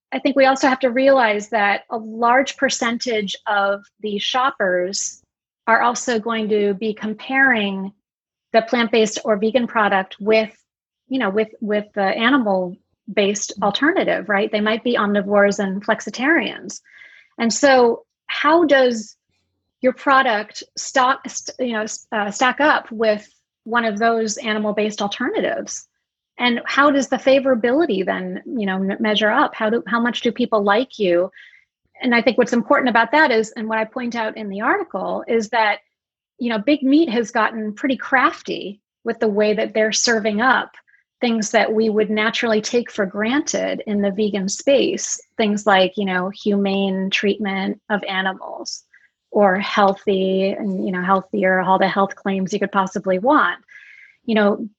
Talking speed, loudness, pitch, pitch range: 160 wpm, -19 LUFS, 220 Hz, 205-250 Hz